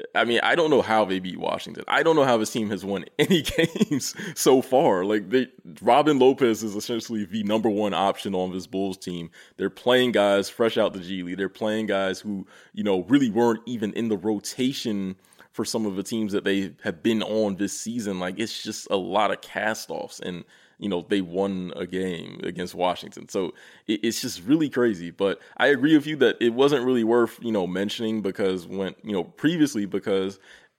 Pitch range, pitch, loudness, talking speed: 95-120 Hz, 110 Hz, -24 LUFS, 210 wpm